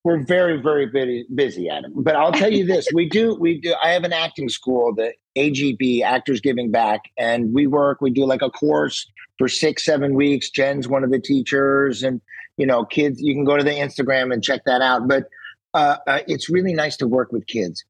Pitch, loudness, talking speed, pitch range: 140 Hz, -19 LUFS, 220 wpm, 130-150 Hz